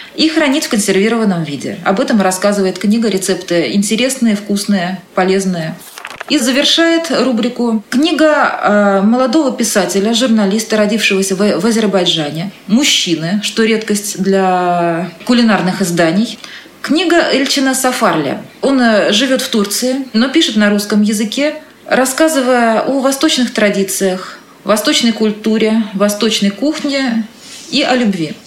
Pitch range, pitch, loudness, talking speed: 200-260 Hz, 220 Hz, -12 LUFS, 110 wpm